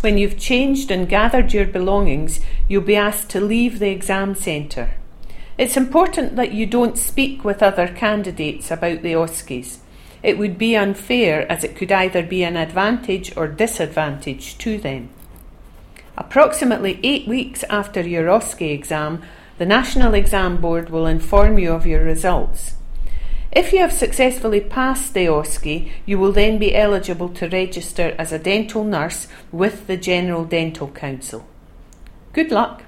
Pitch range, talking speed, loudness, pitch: 160-215 Hz, 155 wpm, -19 LUFS, 190 Hz